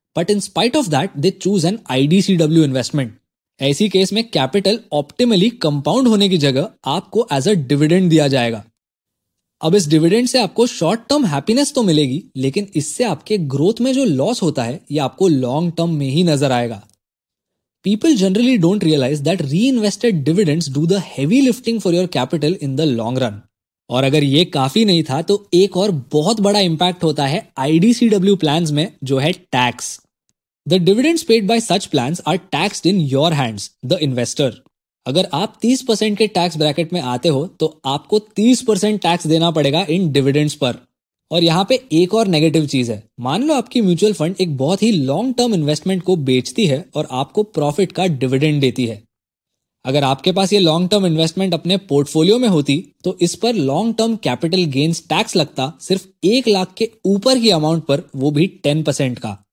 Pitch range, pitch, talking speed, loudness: 145-205 Hz, 170 Hz, 180 wpm, -16 LUFS